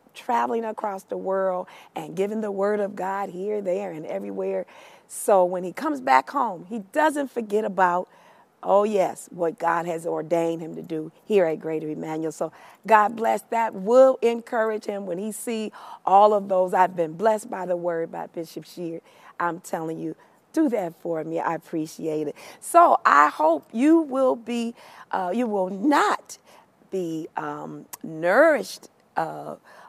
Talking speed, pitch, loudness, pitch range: 165 wpm, 190 Hz, -24 LUFS, 170-225 Hz